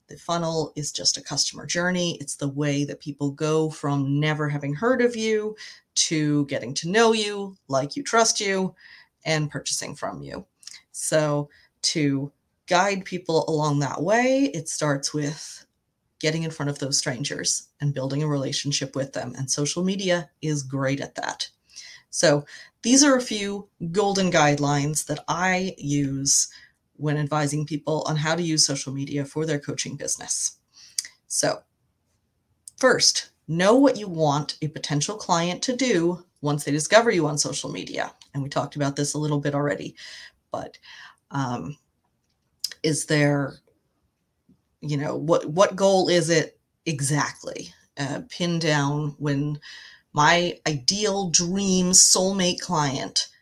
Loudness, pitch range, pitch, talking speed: -23 LUFS, 145-180 Hz, 150 Hz, 150 wpm